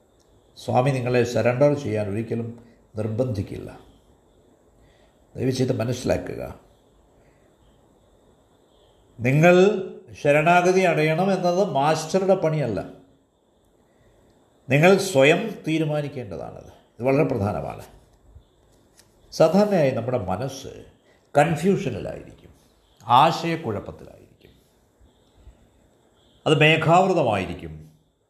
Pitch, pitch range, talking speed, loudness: 135 Hz, 110-165 Hz, 60 wpm, -21 LUFS